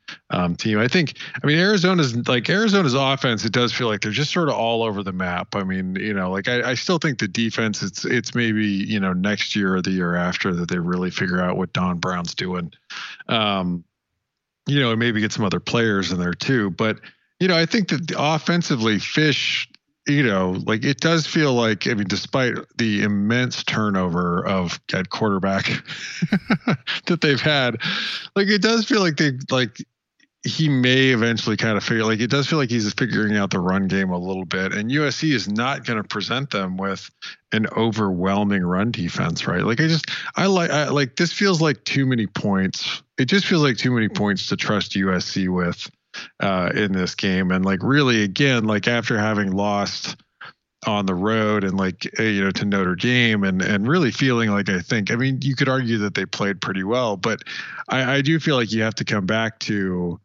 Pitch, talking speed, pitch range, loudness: 110 Hz, 210 wpm, 95-140 Hz, -21 LUFS